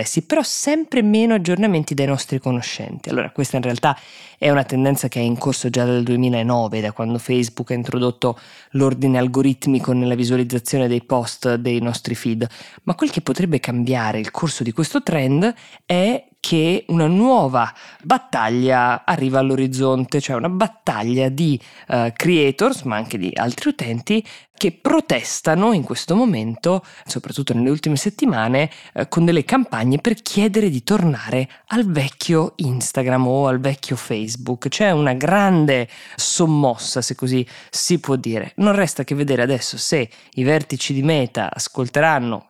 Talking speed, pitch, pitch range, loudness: 150 wpm, 135 Hz, 125-170 Hz, -19 LUFS